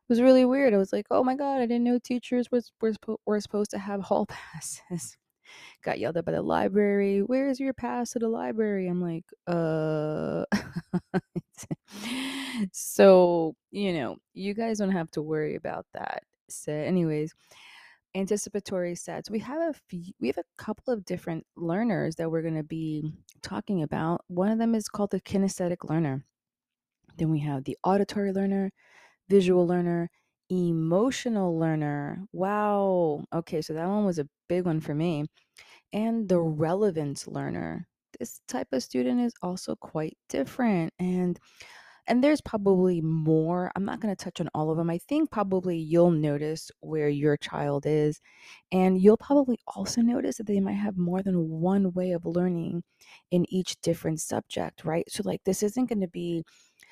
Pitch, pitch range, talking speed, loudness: 185 Hz, 165-210 Hz, 170 wpm, -28 LUFS